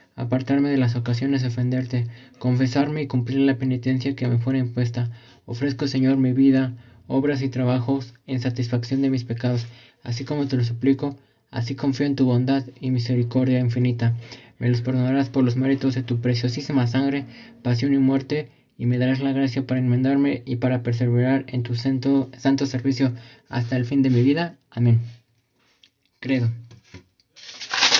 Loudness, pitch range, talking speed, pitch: -23 LUFS, 120-135 Hz, 165 wpm, 130 Hz